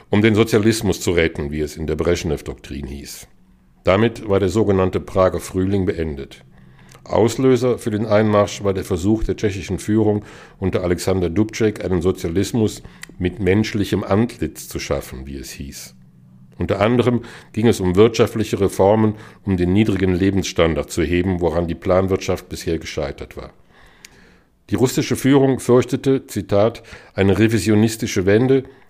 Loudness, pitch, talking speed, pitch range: -19 LUFS, 100 Hz, 140 wpm, 90-110 Hz